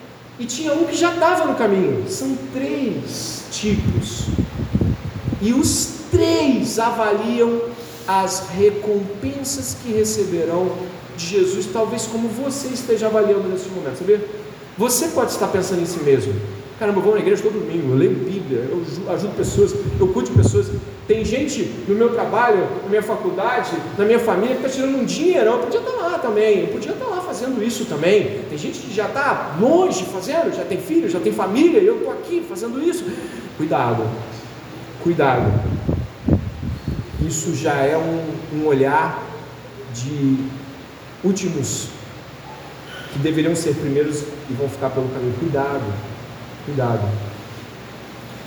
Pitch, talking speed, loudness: 190 Hz, 150 wpm, -20 LUFS